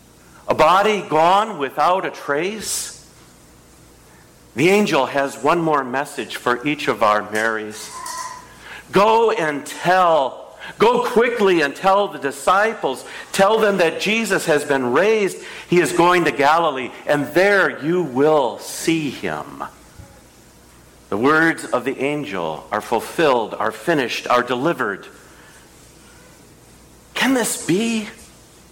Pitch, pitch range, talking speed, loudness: 160 Hz, 135-210 Hz, 120 wpm, -18 LUFS